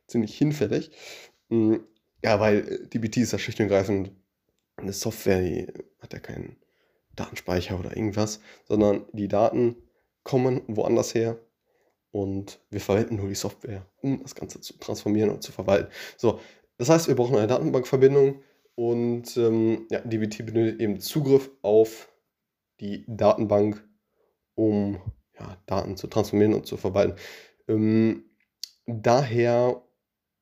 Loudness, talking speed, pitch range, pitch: -25 LUFS, 130 wpm, 100-120 Hz, 110 Hz